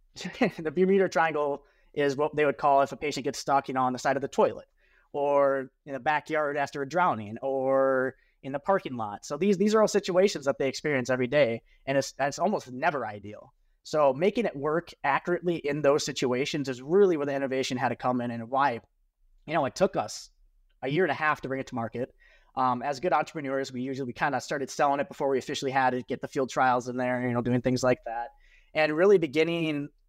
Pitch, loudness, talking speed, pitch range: 140 Hz, -27 LUFS, 230 wpm, 130-155 Hz